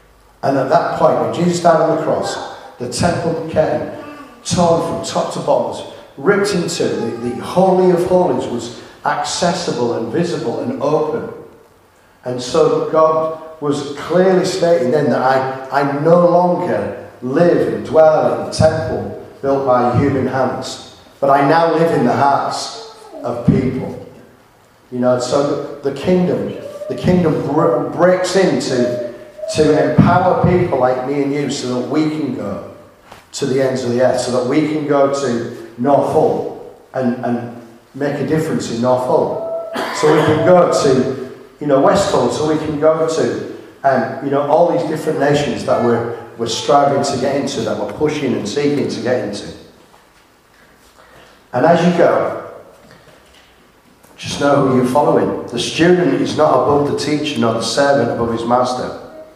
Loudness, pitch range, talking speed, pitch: -15 LUFS, 125-165 Hz, 165 wpm, 145 Hz